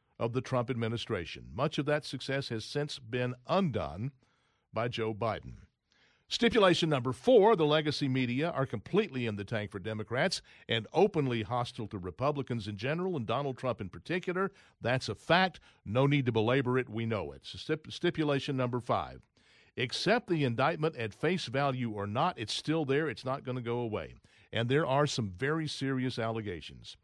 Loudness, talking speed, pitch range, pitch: -32 LUFS, 180 wpm, 115-150 Hz, 130 Hz